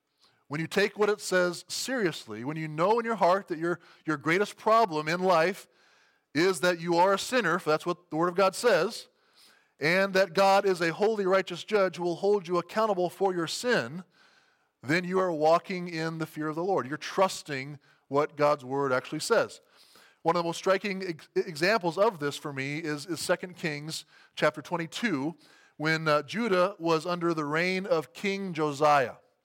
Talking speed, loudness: 190 wpm, -28 LUFS